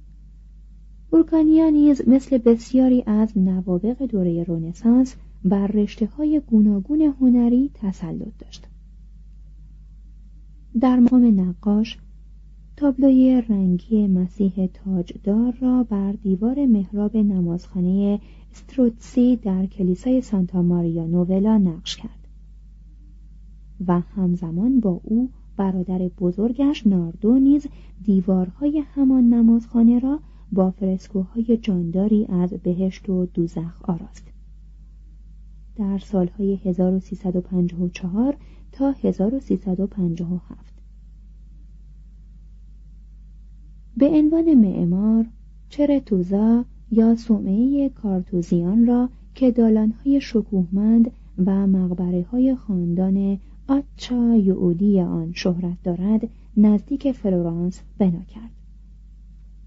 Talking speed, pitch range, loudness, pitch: 85 wpm, 185-240 Hz, -20 LUFS, 205 Hz